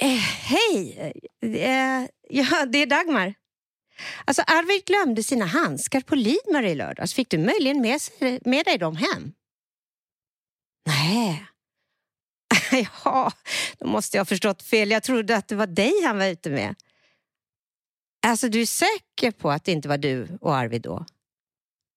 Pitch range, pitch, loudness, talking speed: 195-290 Hz, 250 Hz, -23 LUFS, 155 wpm